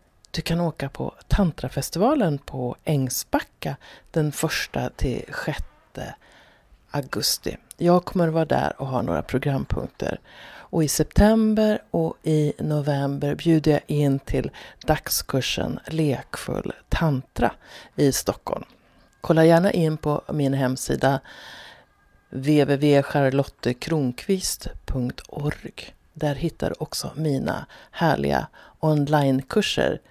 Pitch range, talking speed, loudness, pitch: 135-160 Hz, 95 wpm, -24 LUFS, 150 Hz